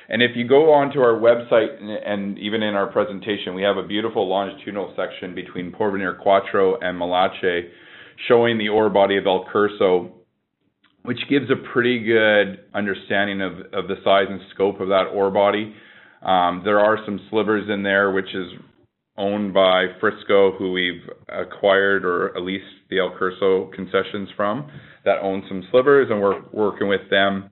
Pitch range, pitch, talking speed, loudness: 95-105 Hz, 100 Hz, 170 wpm, -20 LUFS